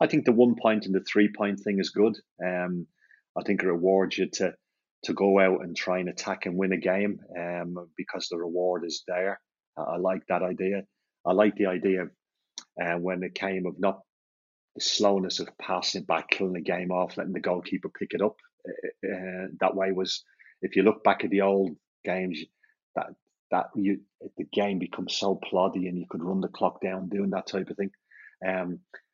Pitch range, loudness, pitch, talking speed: 90-95 Hz, -28 LUFS, 95 Hz, 205 wpm